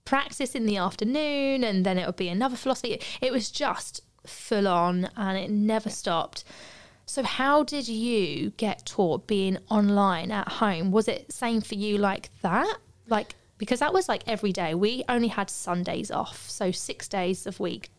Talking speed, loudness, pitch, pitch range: 180 wpm, -27 LUFS, 210 Hz, 190-245 Hz